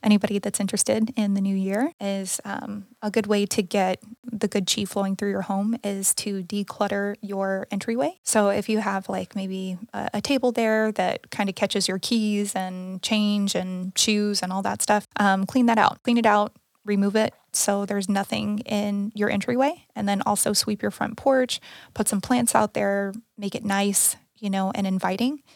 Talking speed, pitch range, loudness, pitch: 195 wpm, 195-220 Hz, -24 LUFS, 205 Hz